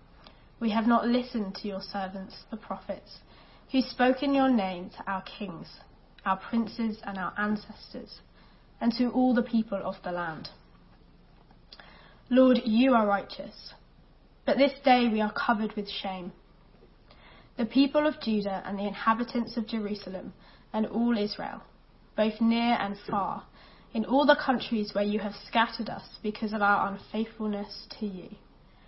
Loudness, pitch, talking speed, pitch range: -28 LUFS, 220 Hz, 150 wpm, 205-240 Hz